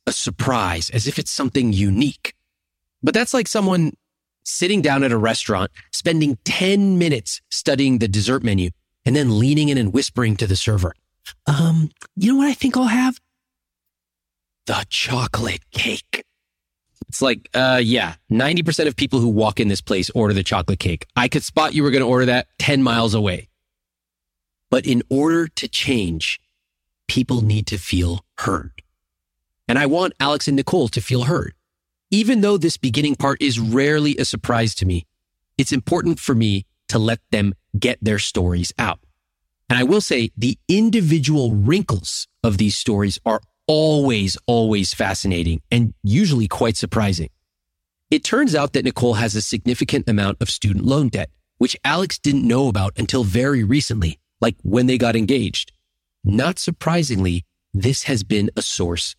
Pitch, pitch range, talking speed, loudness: 115 Hz, 95-140 Hz, 165 wpm, -19 LUFS